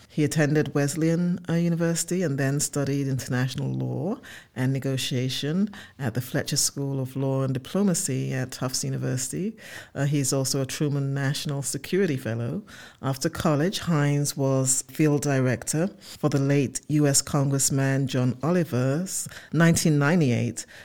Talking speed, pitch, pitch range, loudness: 130 wpm, 140 Hz, 130-155 Hz, -25 LUFS